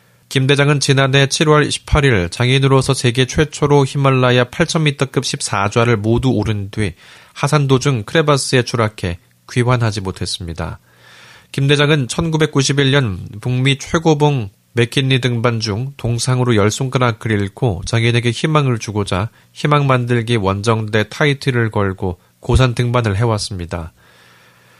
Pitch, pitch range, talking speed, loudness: 125 Hz, 105-140 Hz, 275 characters per minute, -16 LUFS